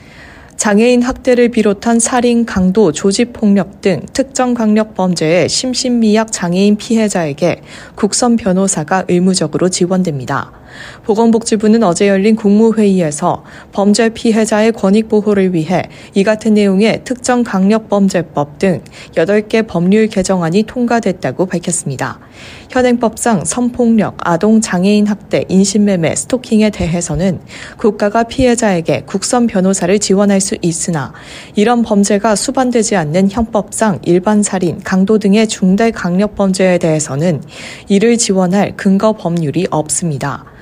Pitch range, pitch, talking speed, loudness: 180-220 Hz, 200 Hz, 305 characters per minute, -12 LUFS